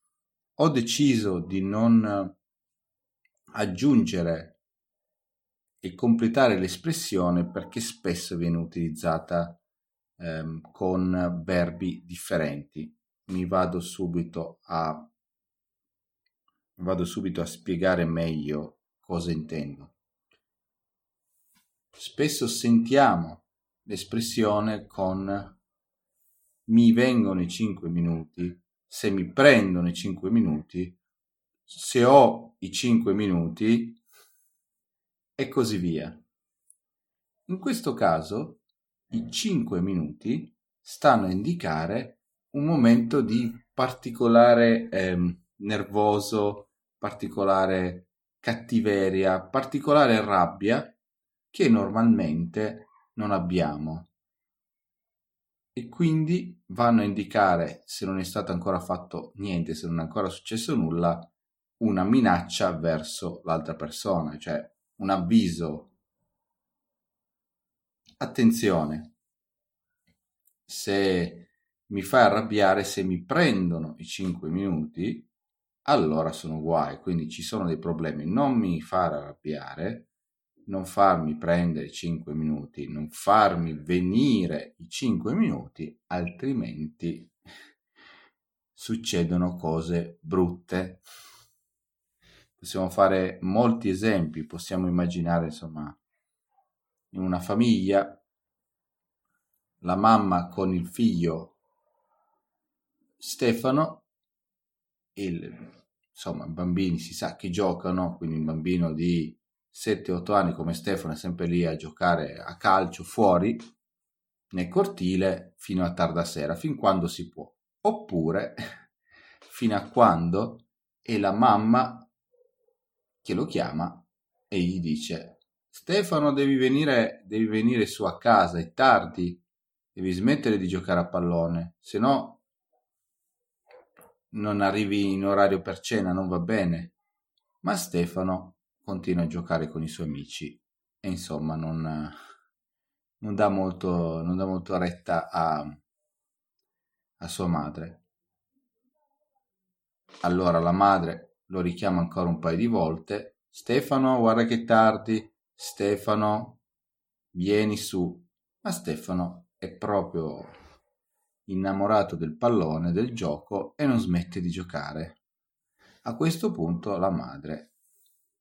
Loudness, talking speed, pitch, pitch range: -26 LUFS, 100 wpm, 95 Hz, 85-110 Hz